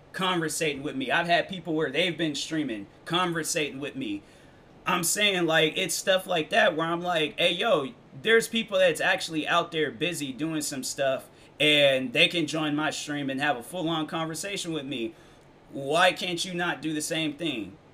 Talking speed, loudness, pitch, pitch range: 185 wpm, -26 LUFS, 160 Hz, 150-180 Hz